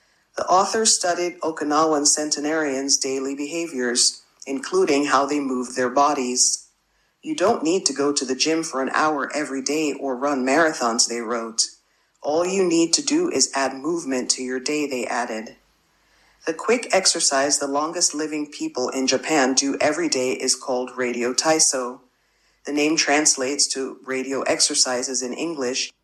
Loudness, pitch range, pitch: -21 LUFS, 130-160 Hz, 140 Hz